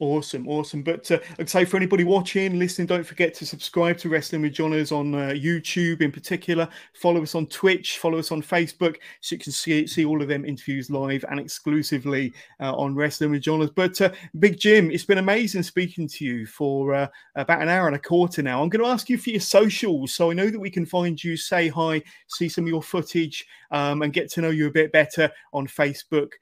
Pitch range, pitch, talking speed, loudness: 150-180 Hz, 165 Hz, 230 wpm, -23 LUFS